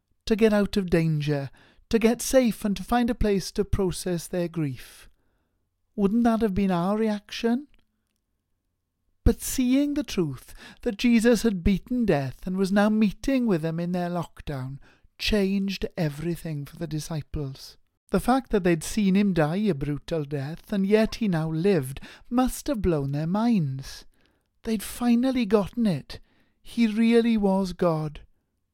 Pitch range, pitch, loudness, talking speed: 150-220 Hz, 190 Hz, -25 LUFS, 155 wpm